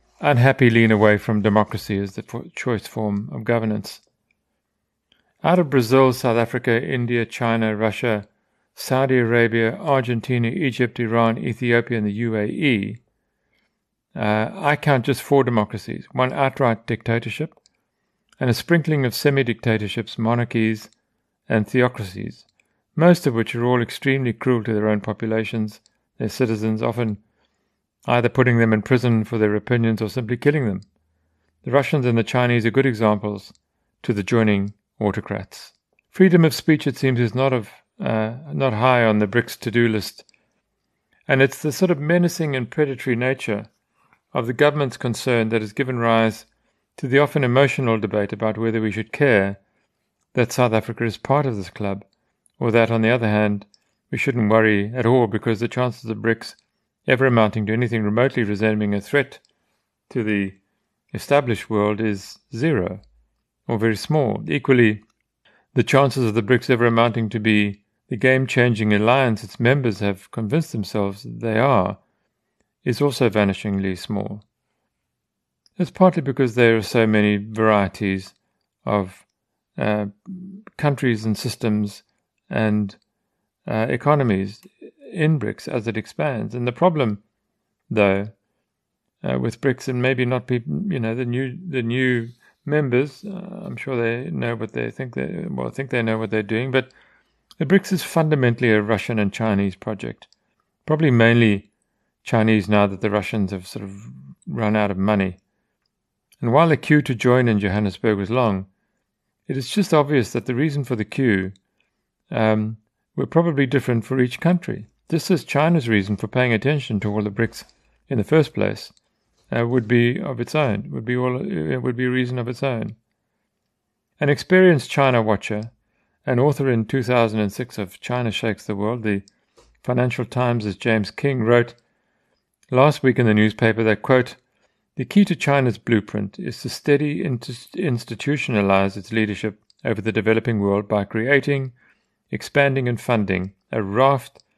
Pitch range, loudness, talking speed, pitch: 105-130 Hz, -20 LUFS, 160 wpm, 115 Hz